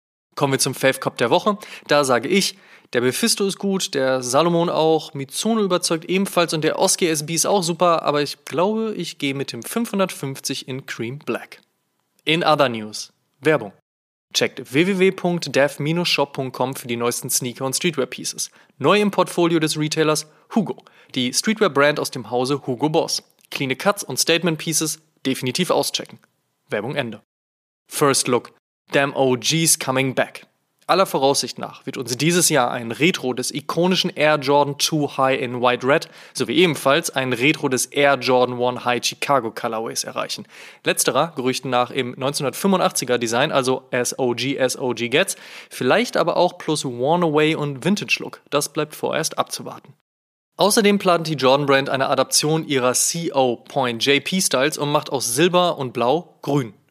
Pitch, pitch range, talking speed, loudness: 145 Hz, 130-170 Hz, 160 wpm, -20 LUFS